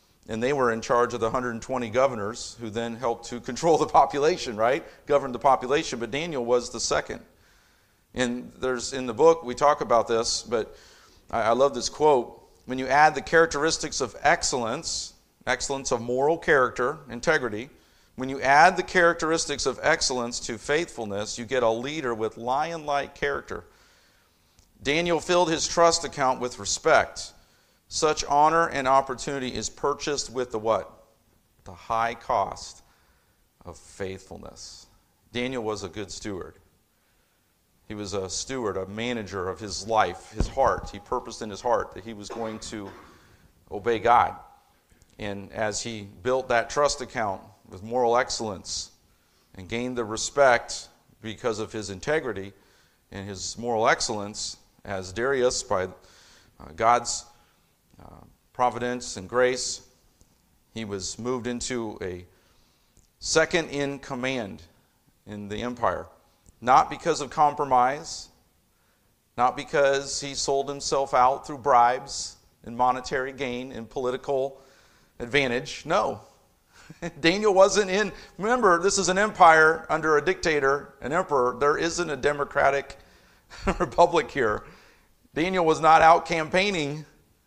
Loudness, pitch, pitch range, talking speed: -25 LUFS, 120 Hz, 105-140 Hz, 140 wpm